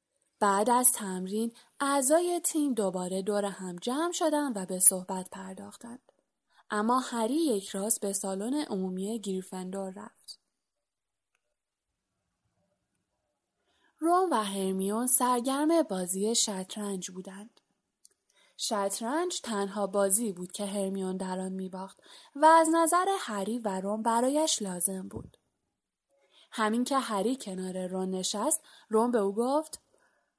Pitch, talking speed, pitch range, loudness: 210 Hz, 115 wpm, 195-270 Hz, -28 LUFS